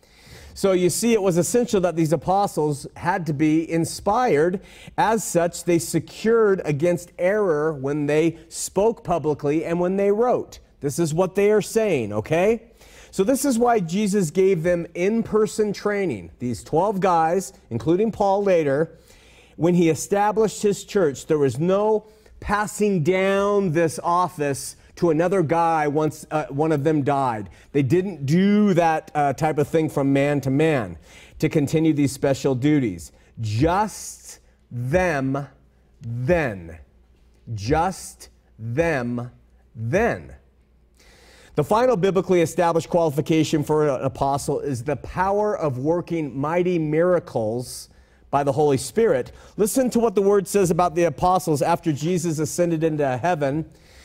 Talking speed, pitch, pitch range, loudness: 140 wpm, 165 Hz, 140-190 Hz, -21 LUFS